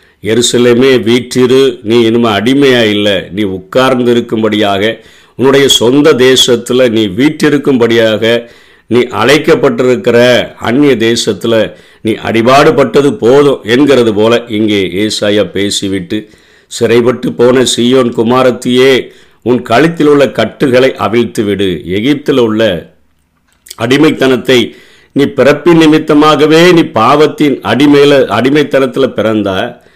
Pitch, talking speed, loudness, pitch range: 120 Hz, 95 wpm, -8 LUFS, 110-135 Hz